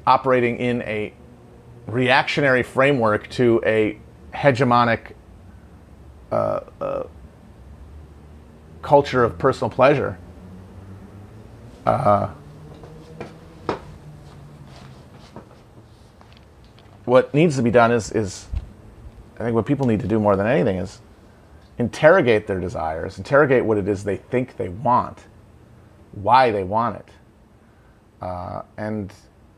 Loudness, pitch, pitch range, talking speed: -20 LUFS, 105 Hz, 95-115 Hz, 100 wpm